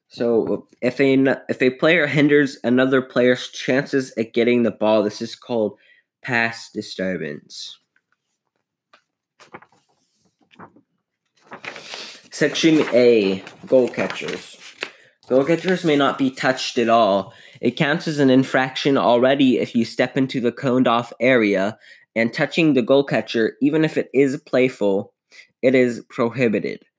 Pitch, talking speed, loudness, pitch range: 130 Hz, 130 wpm, -19 LUFS, 115-140 Hz